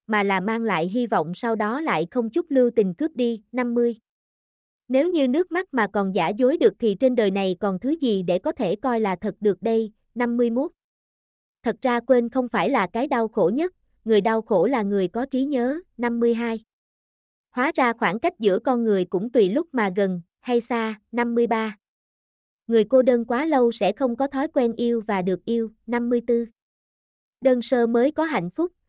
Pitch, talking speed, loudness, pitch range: 235 Hz, 200 wpm, -23 LUFS, 205-255 Hz